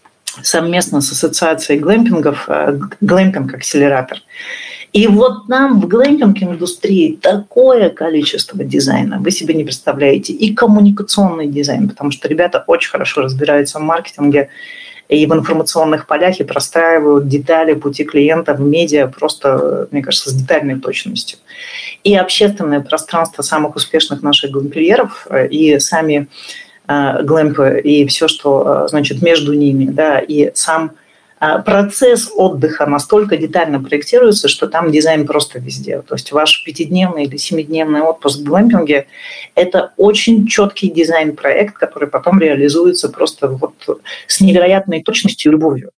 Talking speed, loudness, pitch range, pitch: 130 wpm, -12 LUFS, 145-205 Hz, 160 Hz